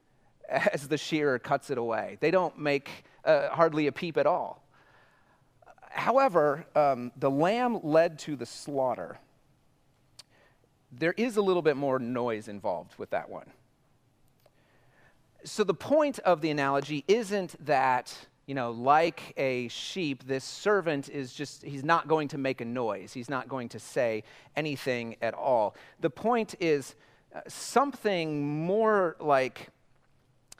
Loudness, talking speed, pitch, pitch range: -29 LUFS, 145 wpm, 145 Hz, 130-165 Hz